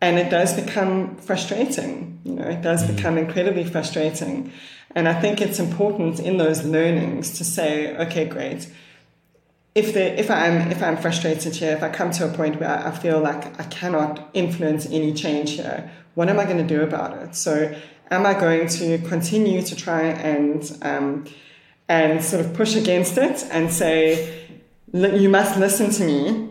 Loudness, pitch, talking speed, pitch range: -21 LUFS, 165 Hz, 180 wpm, 160-190 Hz